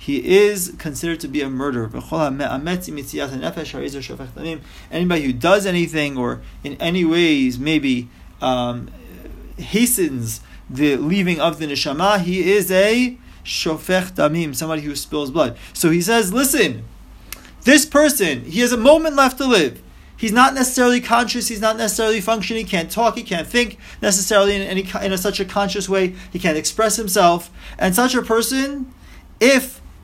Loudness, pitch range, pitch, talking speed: -18 LUFS, 155-225 Hz, 190 Hz, 155 wpm